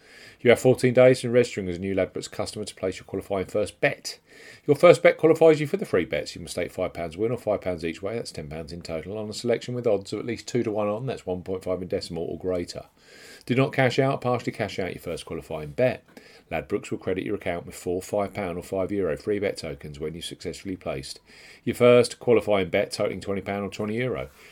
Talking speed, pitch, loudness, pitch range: 255 wpm, 105 Hz, -25 LUFS, 90-120 Hz